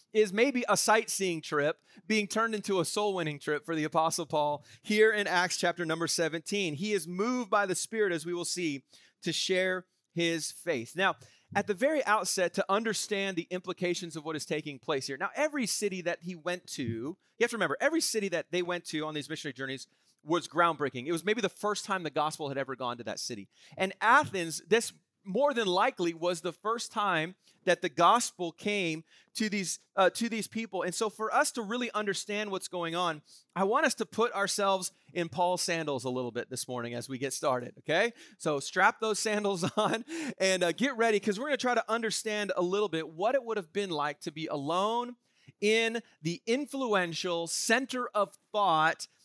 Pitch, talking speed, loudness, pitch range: 185 Hz, 210 wpm, -30 LUFS, 165-215 Hz